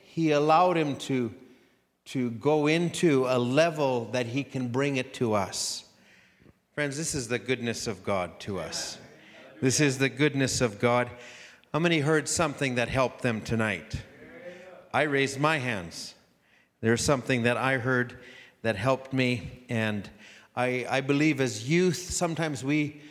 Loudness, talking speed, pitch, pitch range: -27 LUFS, 155 wpm, 130 Hz, 125-150 Hz